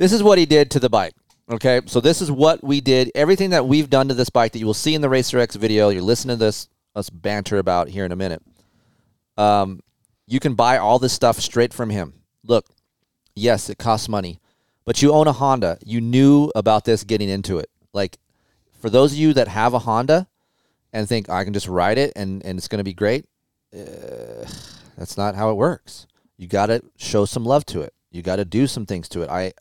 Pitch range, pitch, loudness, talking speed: 100-135 Hz, 115 Hz, -19 LUFS, 235 wpm